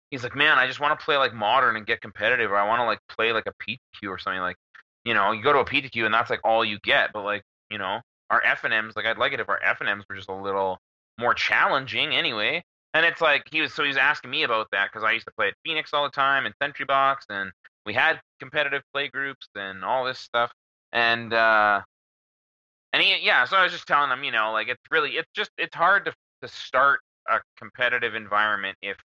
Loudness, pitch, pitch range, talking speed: -23 LUFS, 120 Hz, 105-140 Hz, 250 wpm